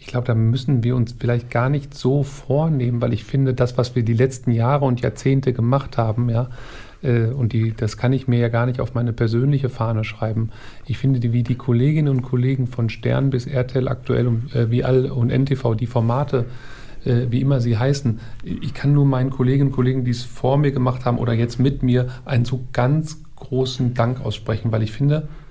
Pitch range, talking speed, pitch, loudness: 120-135 Hz, 210 wpm, 125 Hz, -20 LUFS